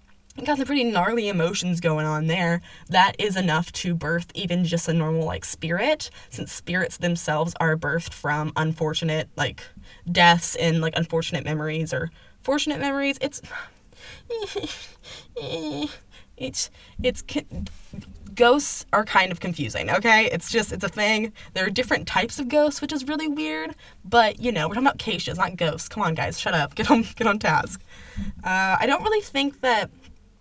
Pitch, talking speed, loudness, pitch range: 180 Hz, 170 wpm, -23 LUFS, 165-250 Hz